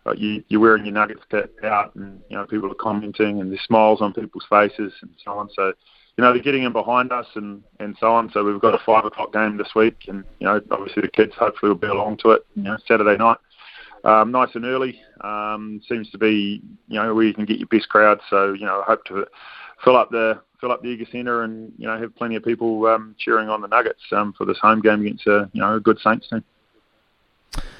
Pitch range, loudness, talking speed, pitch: 105-115 Hz, -19 LUFS, 250 wpm, 110 Hz